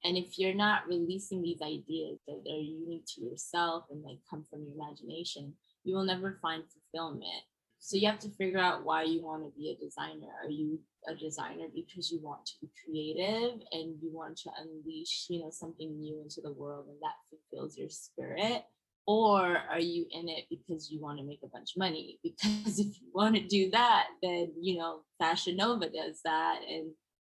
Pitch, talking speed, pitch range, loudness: 165 Hz, 205 wpm, 155-190 Hz, -34 LUFS